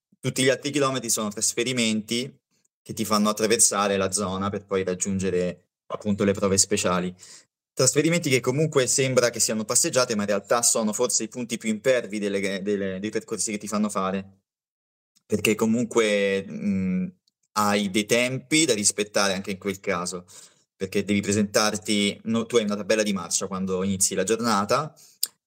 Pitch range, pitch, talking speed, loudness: 100-125 Hz, 105 Hz, 165 wpm, -23 LUFS